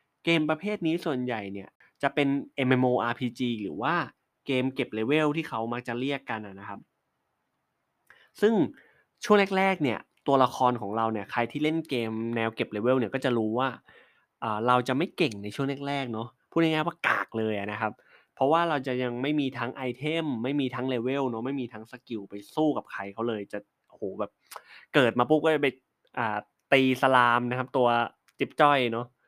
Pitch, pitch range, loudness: 125 Hz, 115-140 Hz, -27 LUFS